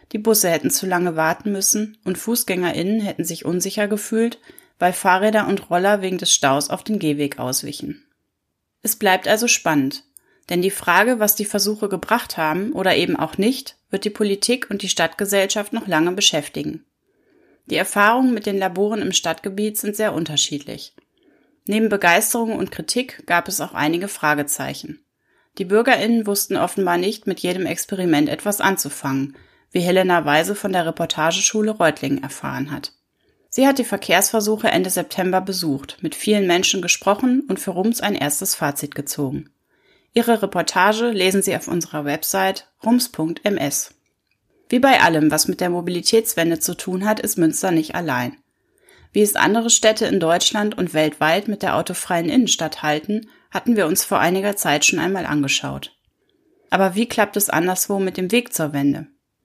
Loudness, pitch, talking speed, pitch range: -19 LUFS, 190 Hz, 160 wpm, 165-215 Hz